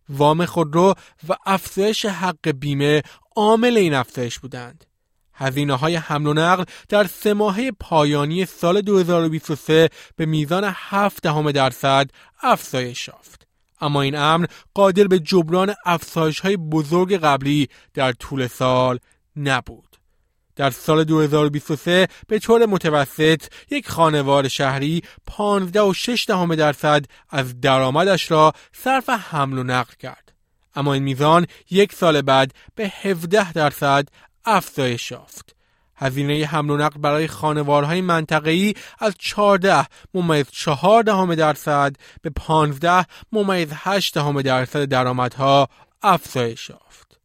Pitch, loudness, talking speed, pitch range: 155 Hz, -19 LUFS, 115 wpm, 140-185 Hz